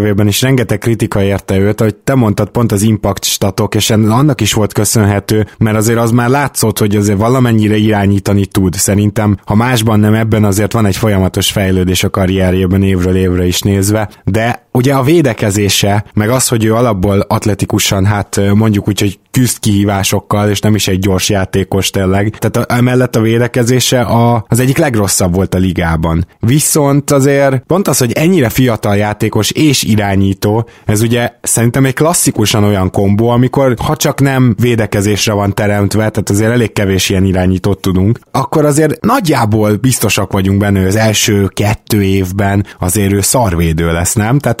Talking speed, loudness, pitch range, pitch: 170 wpm, -11 LUFS, 100-120 Hz, 105 Hz